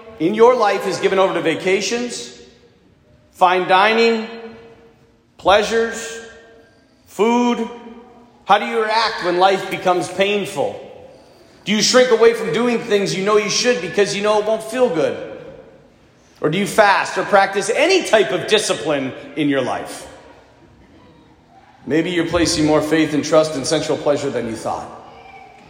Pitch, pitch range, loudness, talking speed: 205 Hz, 175-230 Hz, -17 LUFS, 150 wpm